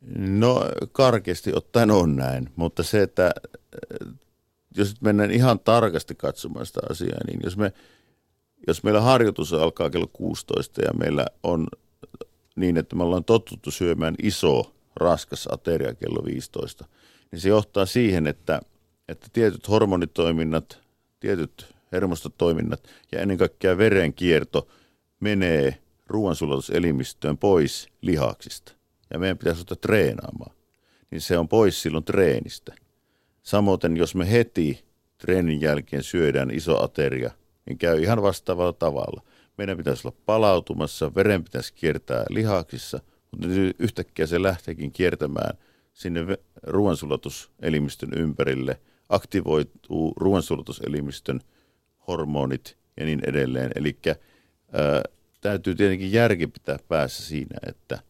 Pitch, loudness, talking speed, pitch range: 90 Hz, -24 LUFS, 115 wpm, 80-100 Hz